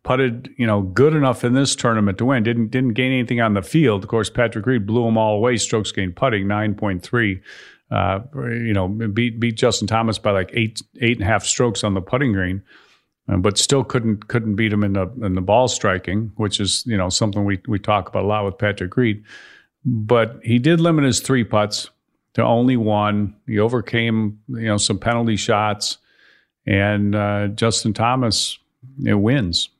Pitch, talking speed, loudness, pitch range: 110 Hz, 200 wpm, -19 LUFS, 105-120 Hz